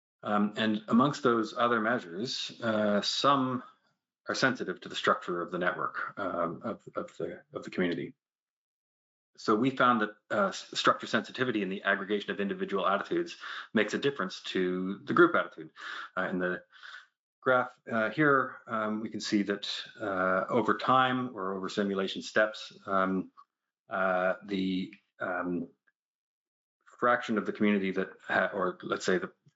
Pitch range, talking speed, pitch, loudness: 95-125 Hz, 150 wpm, 105 Hz, -30 LUFS